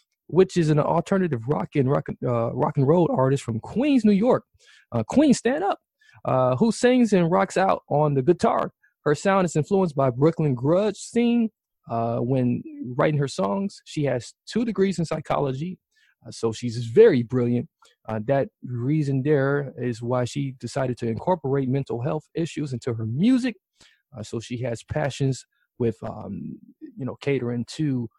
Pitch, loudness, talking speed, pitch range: 145 Hz, -23 LUFS, 170 wpm, 125-190 Hz